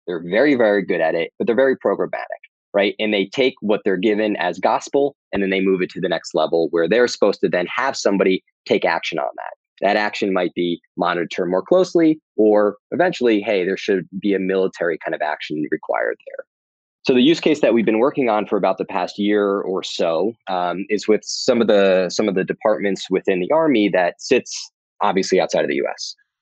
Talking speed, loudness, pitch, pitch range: 215 wpm, -19 LUFS, 105 Hz, 95-145 Hz